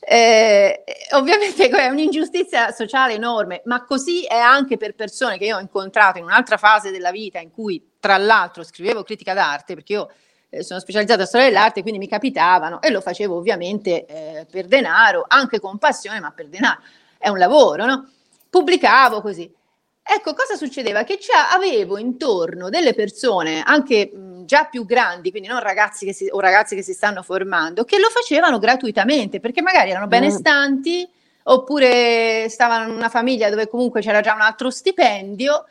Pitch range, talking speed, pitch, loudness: 200-275 Hz, 170 wpm, 225 Hz, -17 LUFS